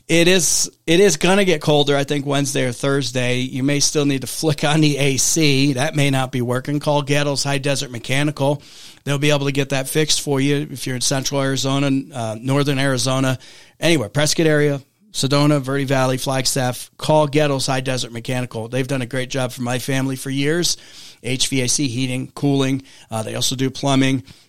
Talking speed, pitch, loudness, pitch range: 195 wpm, 140 Hz, -19 LUFS, 130-145 Hz